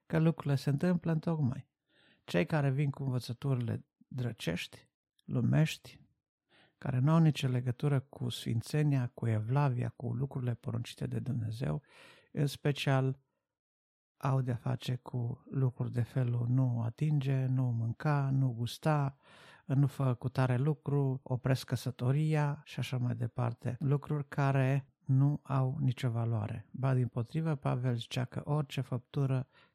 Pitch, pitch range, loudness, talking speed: 130 Hz, 125-145 Hz, -33 LUFS, 135 wpm